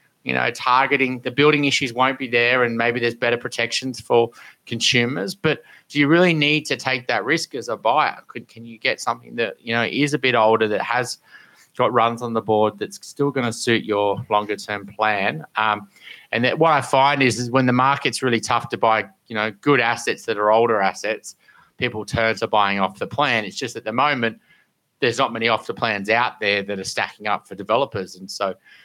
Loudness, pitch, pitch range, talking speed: -20 LUFS, 120 Hz, 110-130 Hz, 225 wpm